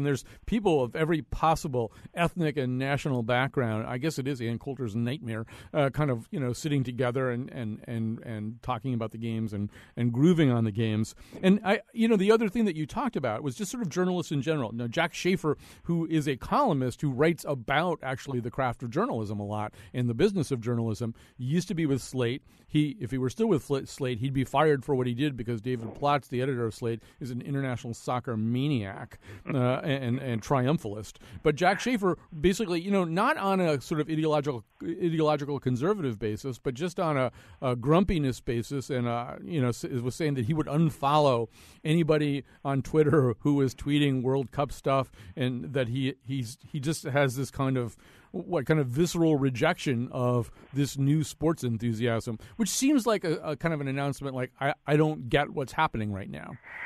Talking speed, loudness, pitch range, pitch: 205 wpm, -29 LUFS, 120-155 Hz, 135 Hz